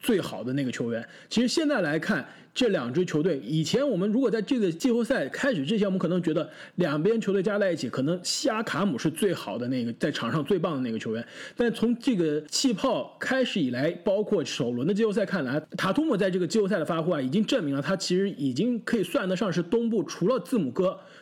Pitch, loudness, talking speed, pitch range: 195 Hz, -27 LUFS, 355 characters per minute, 165-235 Hz